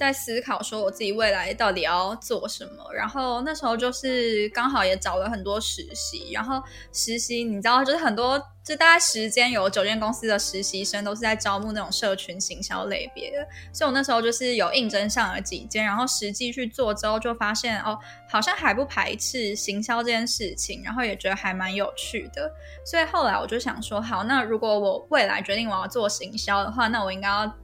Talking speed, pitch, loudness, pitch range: 320 characters per minute, 225 Hz, -24 LUFS, 205-250 Hz